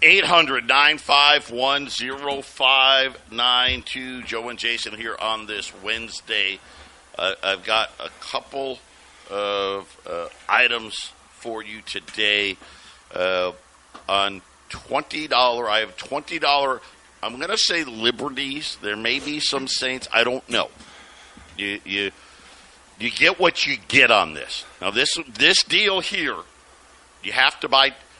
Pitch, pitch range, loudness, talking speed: 120 Hz, 100-135 Hz, -20 LUFS, 120 wpm